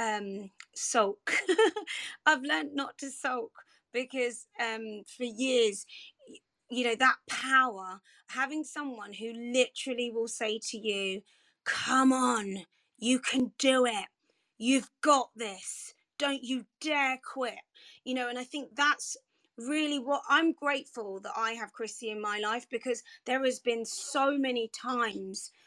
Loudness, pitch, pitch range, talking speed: -31 LUFS, 250 Hz, 225-275 Hz, 140 wpm